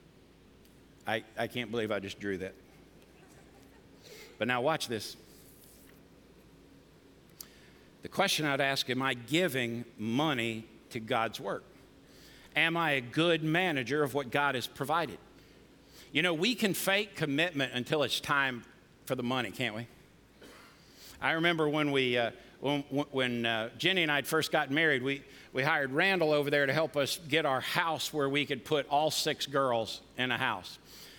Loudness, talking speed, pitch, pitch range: -31 LUFS, 160 wpm, 140 Hz, 120-155 Hz